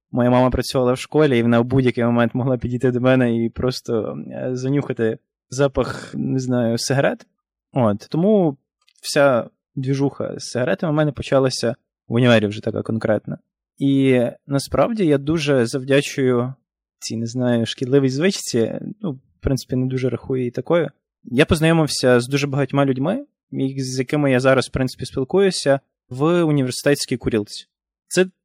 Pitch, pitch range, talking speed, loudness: 130 Hz, 125-145 Hz, 150 wpm, -20 LUFS